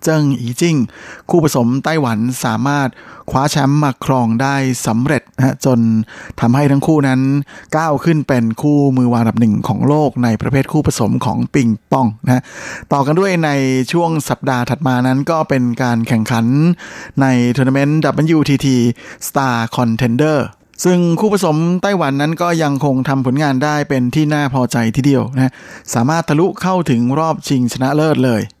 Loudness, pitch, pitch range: -15 LUFS, 135 Hz, 125-150 Hz